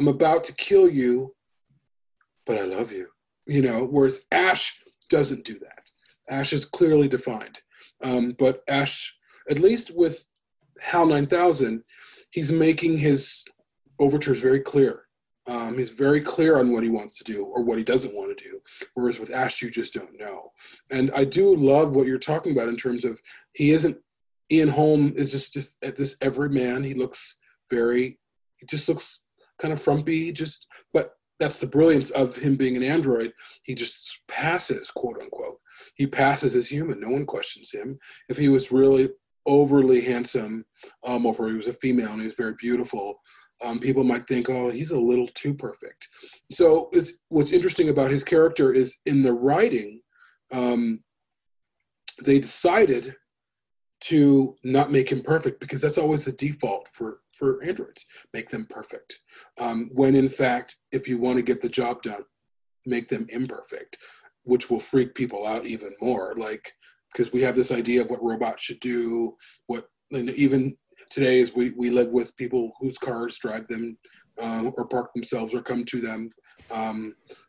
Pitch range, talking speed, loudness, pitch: 125-150 Hz, 175 wpm, -23 LUFS, 130 Hz